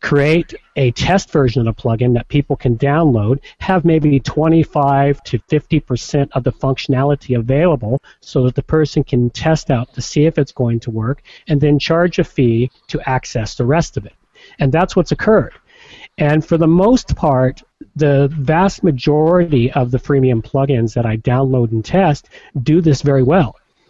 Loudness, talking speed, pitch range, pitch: -15 LUFS, 175 wpm, 130-160 Hz, 140 Hz